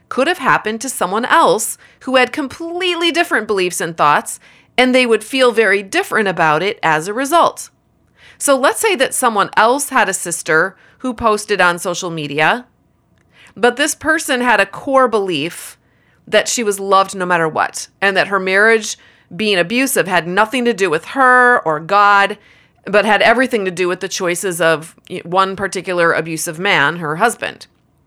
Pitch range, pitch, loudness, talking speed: 185-255 Hz, 210 Hz, -14 LUFS, 175 wpm